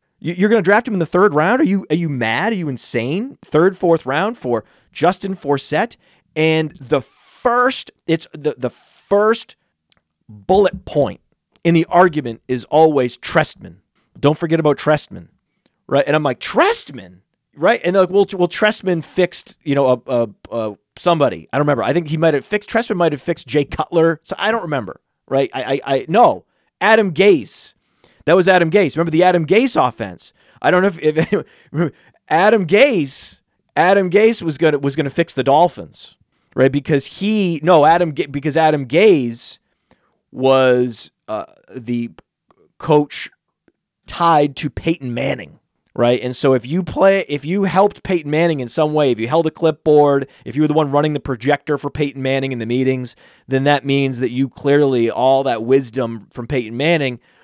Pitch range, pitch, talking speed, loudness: 135-180 Hz, 155 Hz, 180 wpm, -16 LUFS